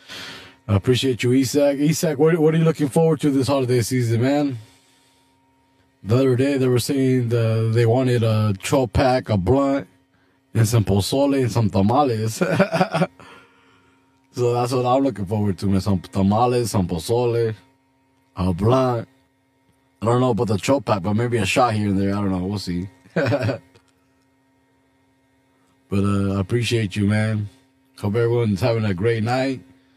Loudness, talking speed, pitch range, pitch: -20 LUFS, 160 wpm, 100-135 Hz, 120 Hz